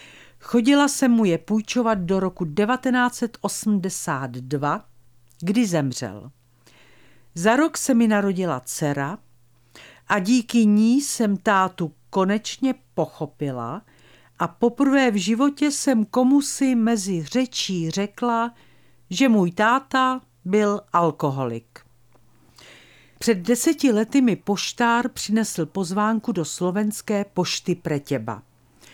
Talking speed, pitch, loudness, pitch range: 105 wpm, 200 Hz, -22 LUFS, 150-235 Hz